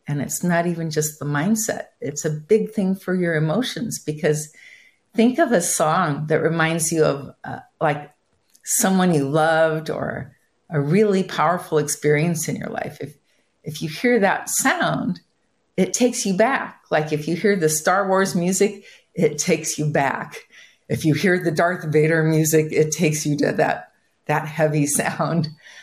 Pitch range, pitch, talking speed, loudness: 155-190 Hz, 160 Hz, 170 wpm, -20 LUFS